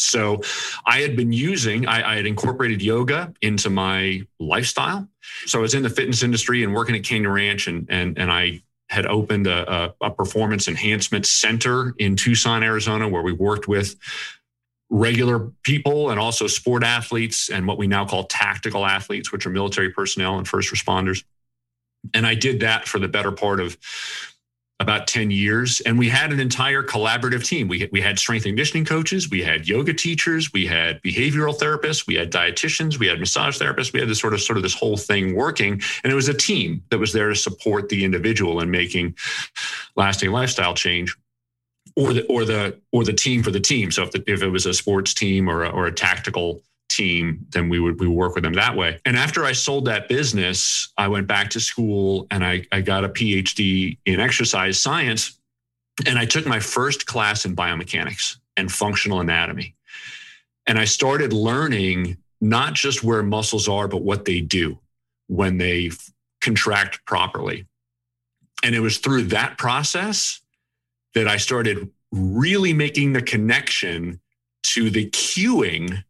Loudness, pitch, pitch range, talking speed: -20 LUFS, 105 Hz, 95-120 Hz, 185 wpm